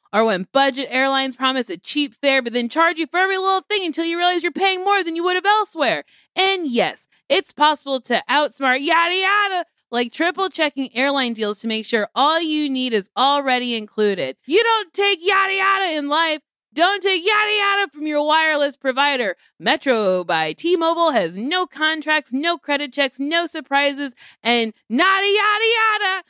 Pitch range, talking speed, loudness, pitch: 265-365 Hz, 180 wpm, -18 LUFS, 310 Hz